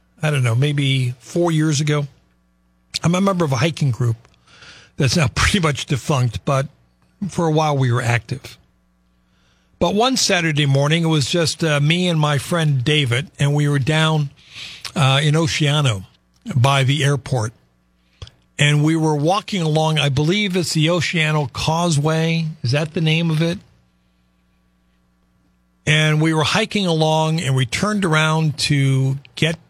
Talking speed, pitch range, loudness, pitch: 155 wpm, 120-160 Hz, -18 LUFS, 145 Hz